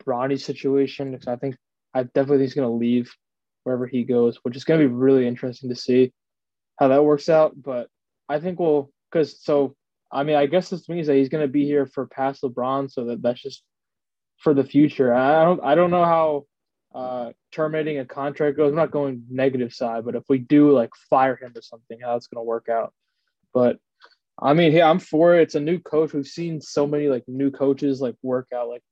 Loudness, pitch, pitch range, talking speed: -21 LUFS, 135 Hz, 125-150 Hz, 220 wpm